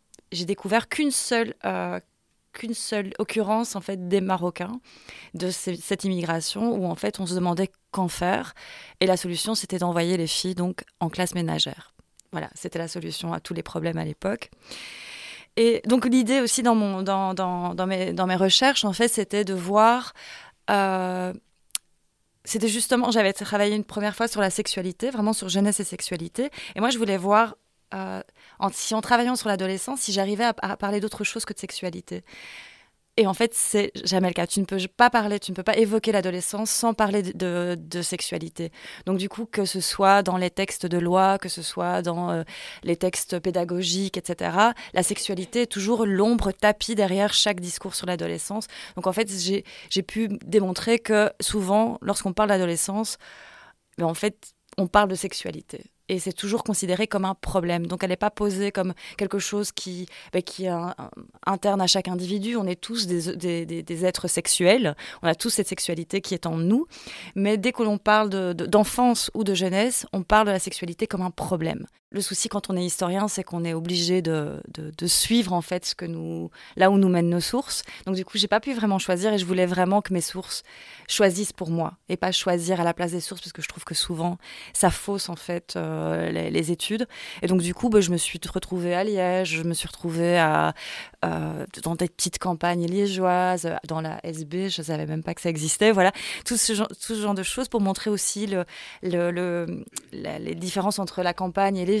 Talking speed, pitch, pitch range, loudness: 210 wpm, 190 Hz, 175-210 Hz, -24 LUFS